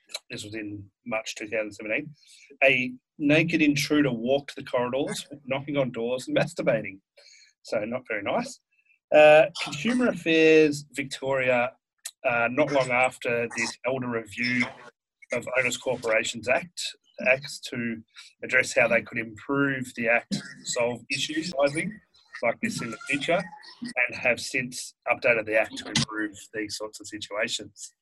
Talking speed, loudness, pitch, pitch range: 135 wpm, -25 LUFS, 135 Hz, 115-150 Hz